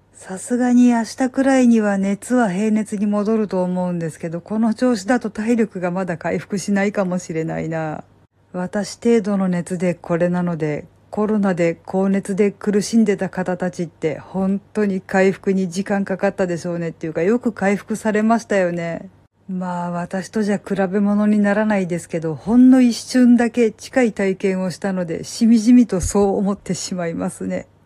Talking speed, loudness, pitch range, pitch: 345 characters per minute, -19 LUFS, 175-215 Hz, 195 Hz